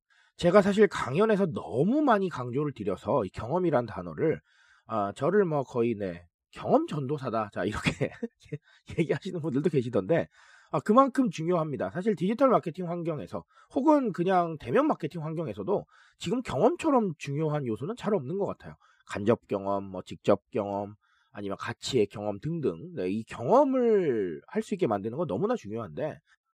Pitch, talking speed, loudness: 170 Hz, 330 characters per minute, -28 LUFS